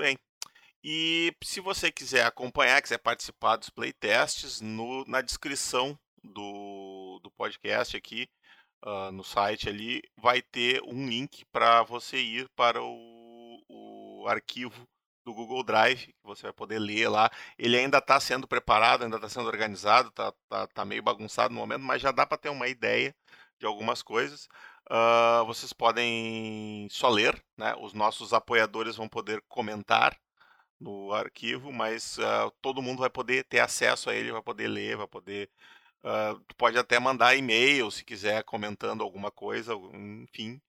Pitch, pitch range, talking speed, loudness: 115 Hz, 110-130 Hz, 155 wpm, -28 LUFS